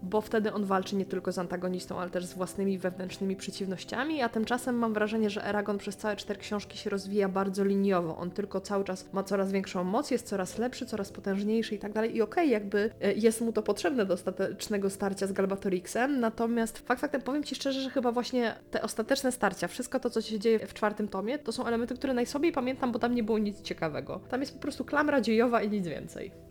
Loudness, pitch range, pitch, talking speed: -31 LUFS, 195-240 Hz, 210 Hz, 225 wpm